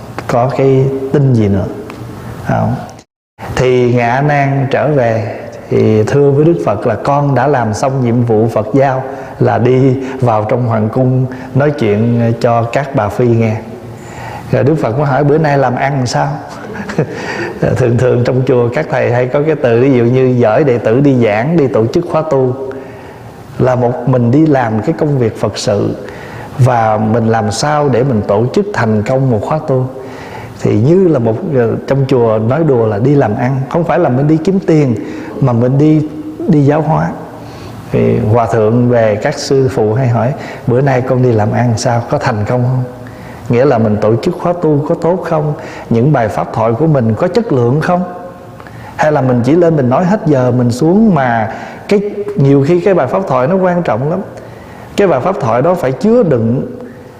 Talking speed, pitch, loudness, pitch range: 200 wpm, 130 Hz, -12 LUFS, 115-145 Hz